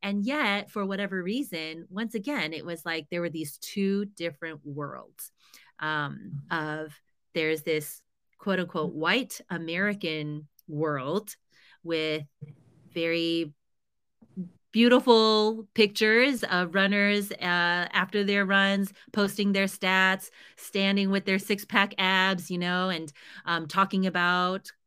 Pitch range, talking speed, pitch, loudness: 165-200 Hz, 120 wpm, 185 Hz, -27 LUFS